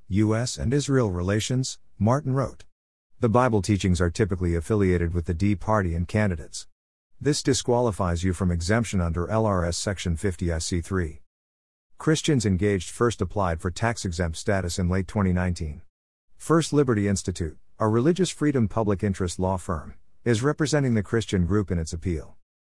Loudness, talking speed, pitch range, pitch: -25 LUFS, 150 wpm, 85-115 Hz, 95 Hz